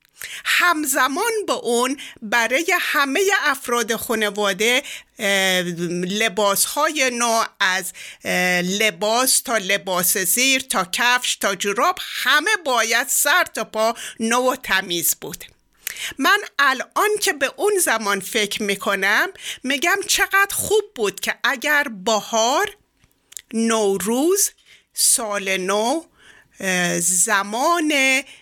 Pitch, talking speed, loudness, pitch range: 235 Hz, 100 wpm, -19 LUFS, 205-300 Hz